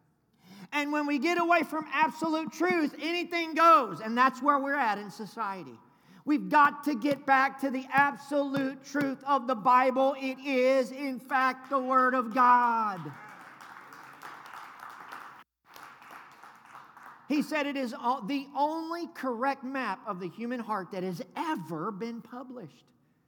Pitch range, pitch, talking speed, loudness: 245-290 Hz, 270 Hz, 140 wpm, -28 LUFS